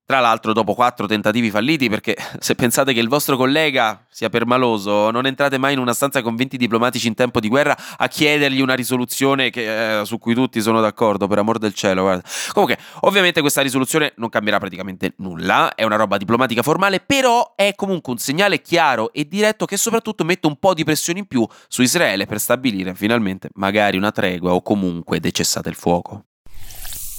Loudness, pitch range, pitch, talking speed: -18 LUFS, 105-140 Hz, 120 Hz, 195 wpm